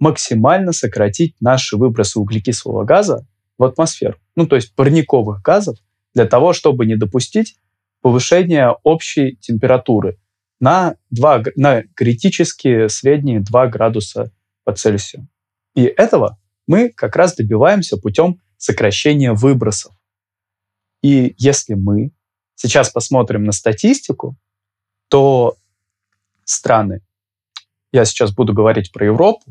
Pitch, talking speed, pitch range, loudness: 115 Hz, 110 wpm, 105-140 Hz, -14 LUFS